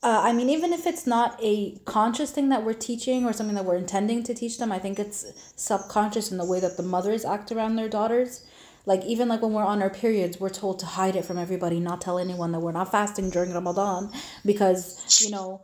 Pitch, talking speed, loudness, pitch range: 205 Hz, 240 wpm, -25 LUFS, 185-230 Hz